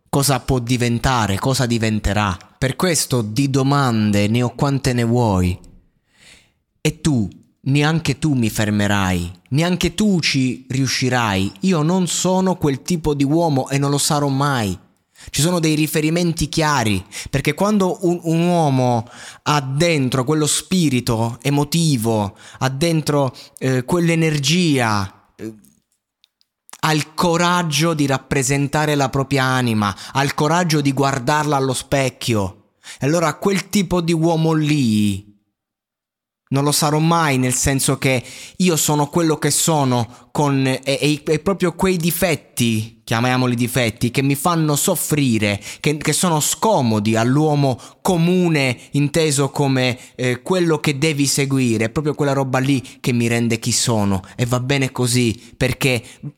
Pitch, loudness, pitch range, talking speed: 140 Hz, -18 LUFS, 120-155 Hz, 140 wpm